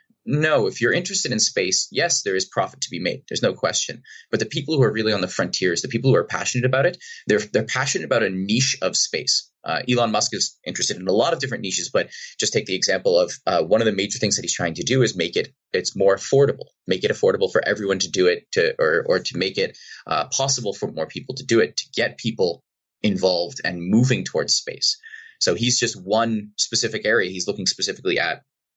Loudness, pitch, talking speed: -21 LUFS, 130 Hz, 240 wpm